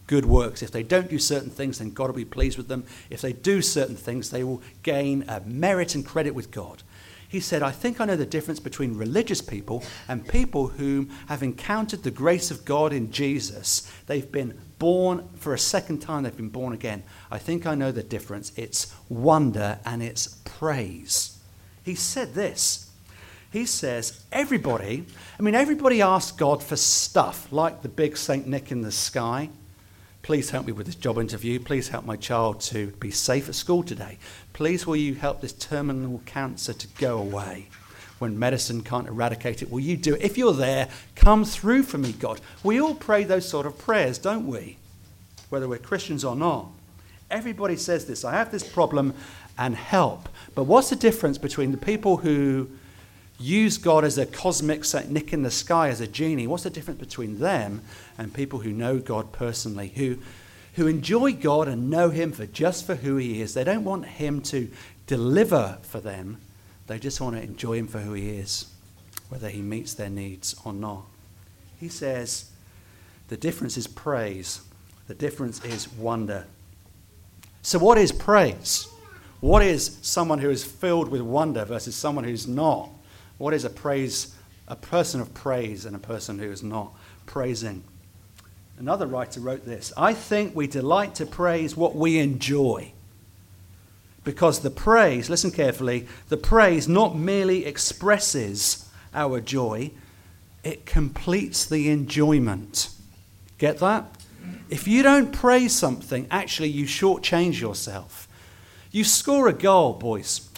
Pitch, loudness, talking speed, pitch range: 130 Hz, -24 LUFS, 170 wpm, 105-155 Hz